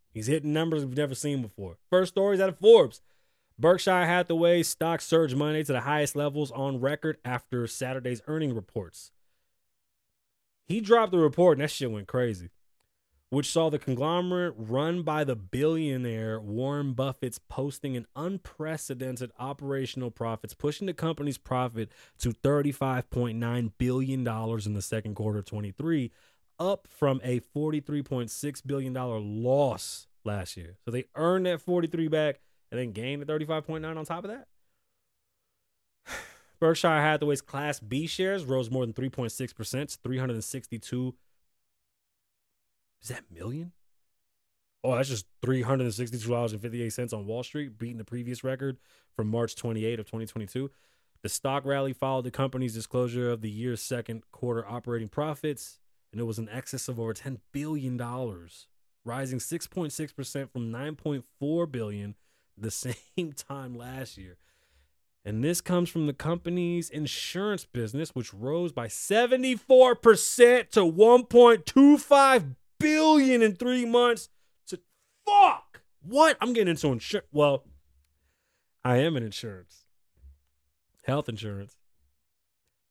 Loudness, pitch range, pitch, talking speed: -27 LUFS, 115-155 Hz, 130 Hz, 145 wpm